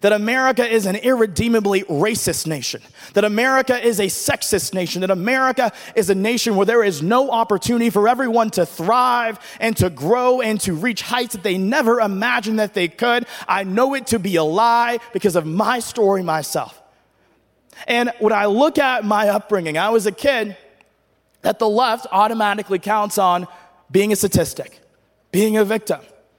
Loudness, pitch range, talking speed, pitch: -18 LUFS, 195-235 Hz, 175 wpm, 215 Hz